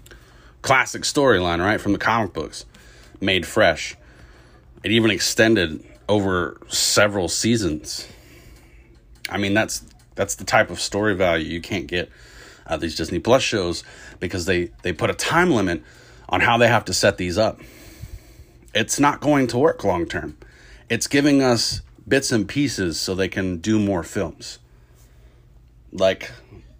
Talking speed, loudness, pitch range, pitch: 150 wpm, -20 LUFS, 85-120 Hz, 95 Hz